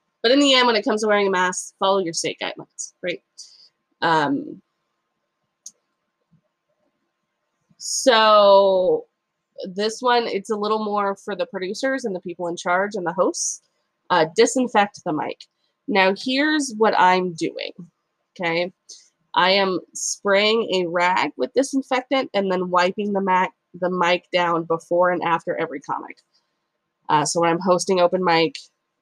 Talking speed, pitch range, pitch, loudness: 150 wpm, 180-220 Hz, 195 Hz, -20 LUFS